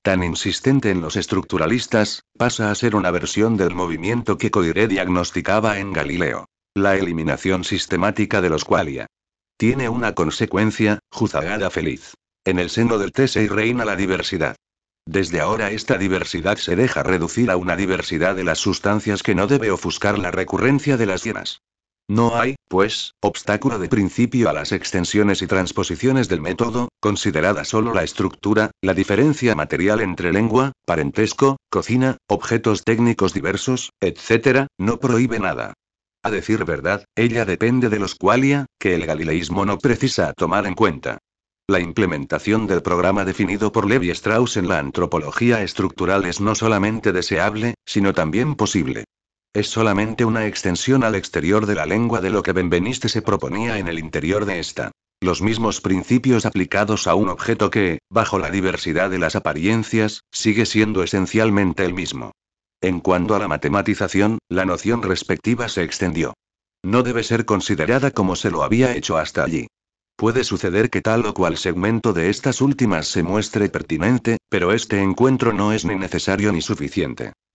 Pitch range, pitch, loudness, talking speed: 95-115 Hz, 105 Hz, -20 LUFS, 160 wpm